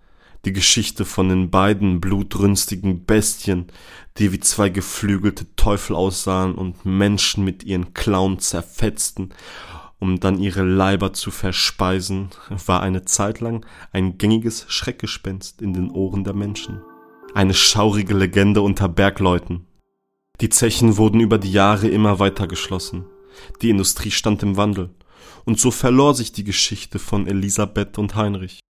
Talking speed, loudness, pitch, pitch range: 140 wpm, -19 LUFS, 100 Hz, 95-105 Hz